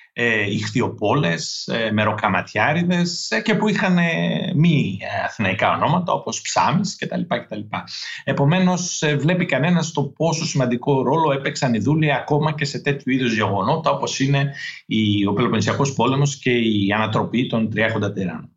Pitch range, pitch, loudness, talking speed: 115-160 Hz, 140 Hz, -20 LUFS, 150 wpm